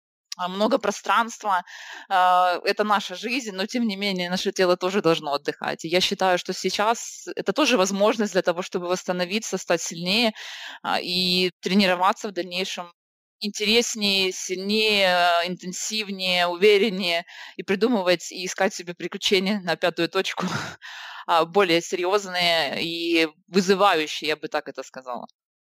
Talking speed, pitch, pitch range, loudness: 125 wpm, 185 Hz, 175-205 Hz, -23 LUFS